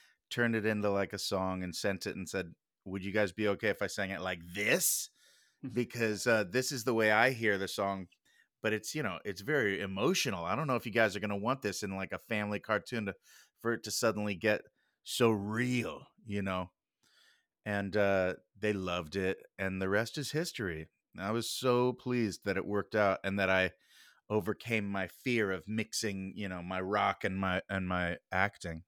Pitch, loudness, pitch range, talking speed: 100 Hz, -33 LUFS, 95-110 Hz, 205 wpm